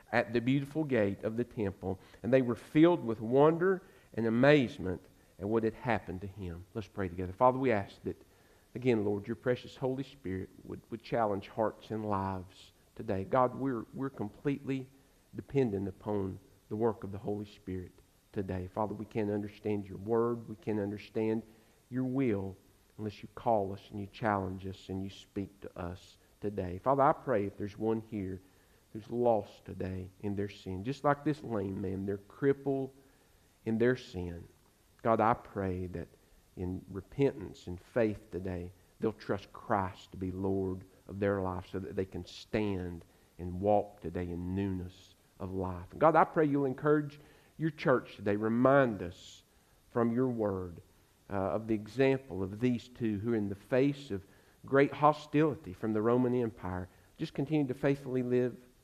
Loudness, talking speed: -33 LUFS, 175 wpm